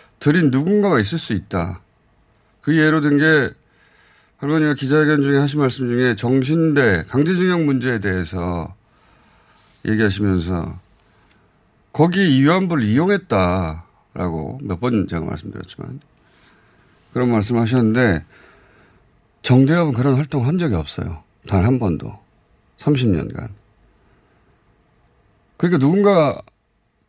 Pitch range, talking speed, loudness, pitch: 100-150 Hz, 245 characters per minute, -18 LUFS, 125 Hz